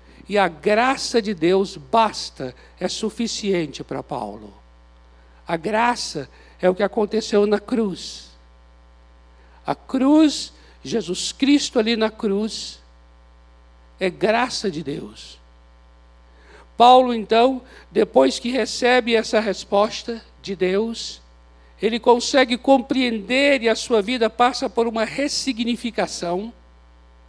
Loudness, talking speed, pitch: -20 LUFS, 110 wpm, 205 Hz